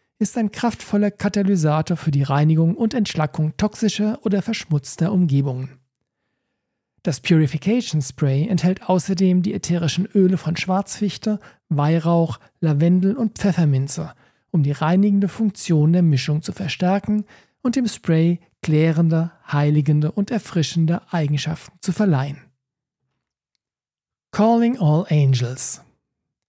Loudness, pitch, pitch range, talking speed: -20 LUFS, 170 Hz, 150-200 Hz, 110 wpm